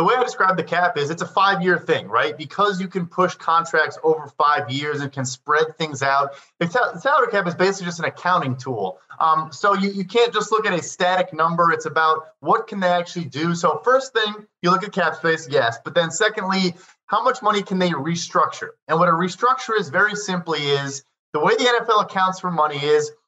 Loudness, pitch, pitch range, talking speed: -20 LUFS, 175 Hz, 155-200 Hz, 220 wpm